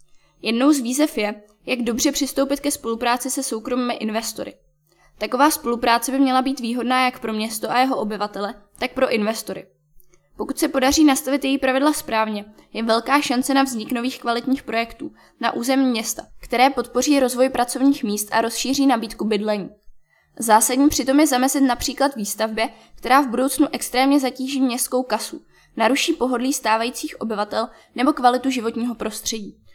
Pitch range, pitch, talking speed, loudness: 225-270 Hz, 245 Hz, 150 wpm, -20 LUFS